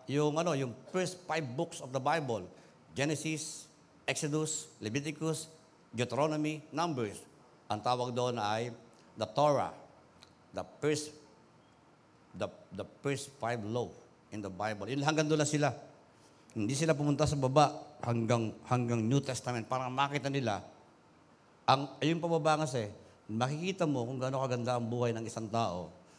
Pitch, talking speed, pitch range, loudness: 140 Hz, 140 wpm, 120-155 Hz, -34 LUFS